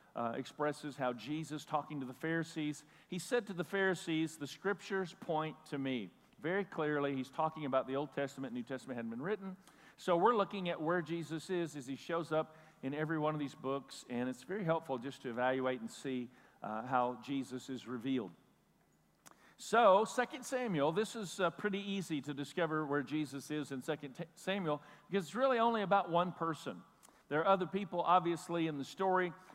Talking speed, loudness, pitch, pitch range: 190 wpm, -37 LUFS, 155 Hz, 135-185 Hz